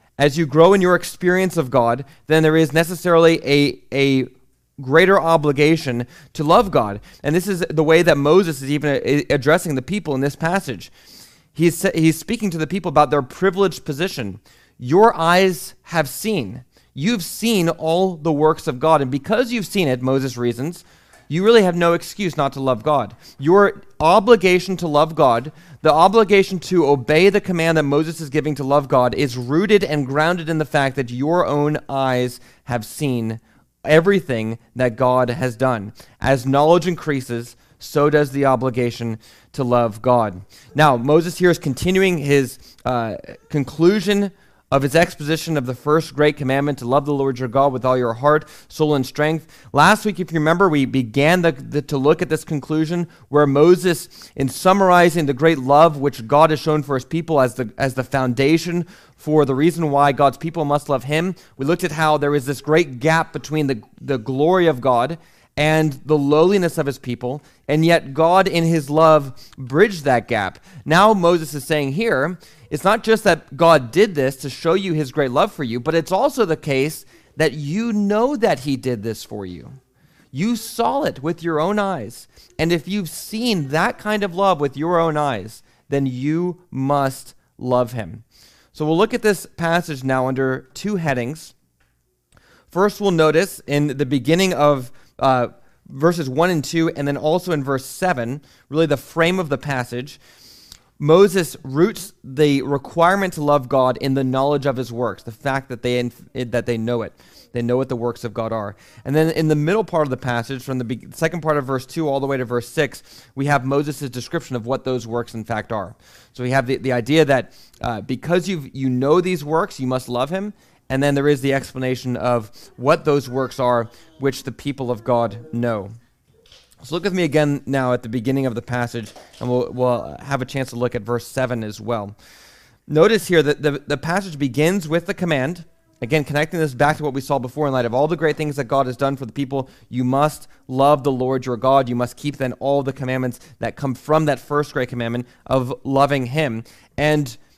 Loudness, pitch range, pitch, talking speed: -19 LUFS, 130-165 Hz, 145 Hz, 200 wpm